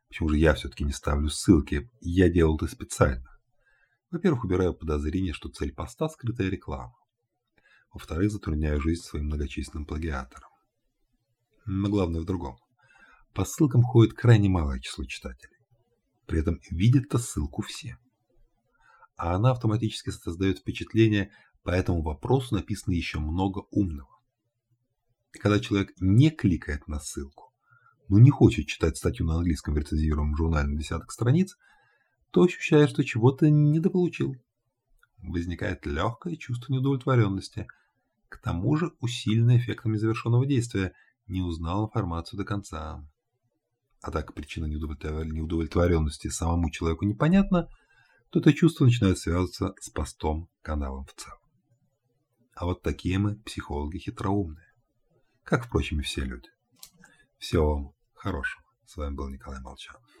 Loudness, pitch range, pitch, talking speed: -27 LUFS, 80-120 Hz, 100 Hz, 130 wpm